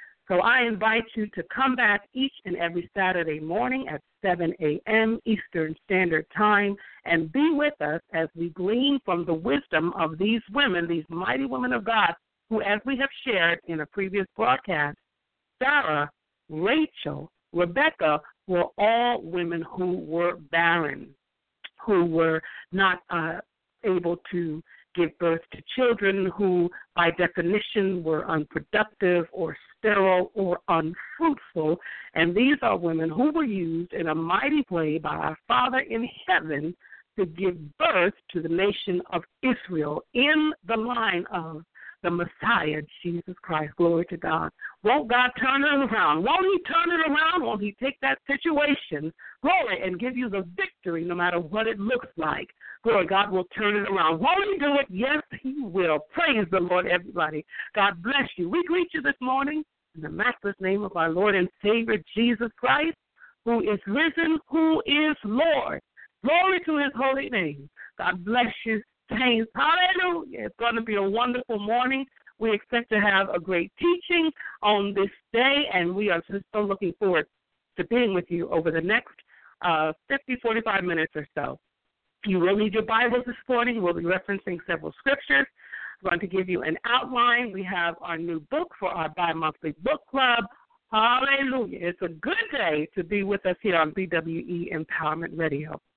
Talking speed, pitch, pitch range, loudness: 170 wpm, 200 Hz, 170-250 Hz, -25 LUFS